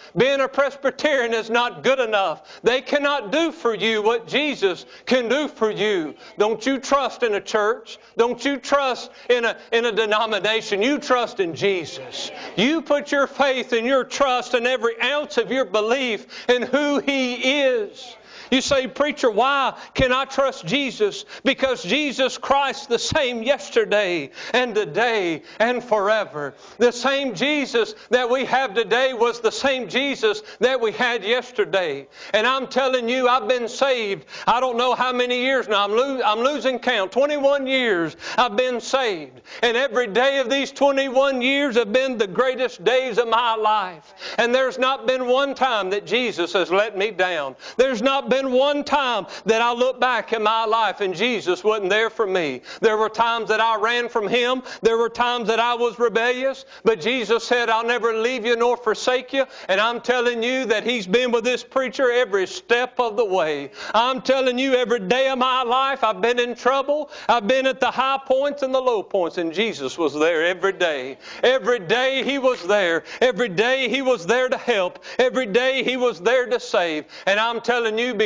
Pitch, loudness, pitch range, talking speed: 245 Hz, -21 LUFS, 225-265 Hz, 190 wpm